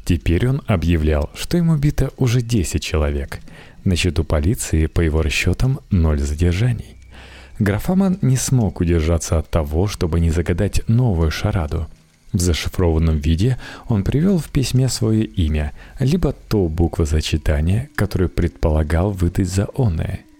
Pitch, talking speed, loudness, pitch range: 90 Hz, 135 wpm, -19 LUFS, 80-115 Hz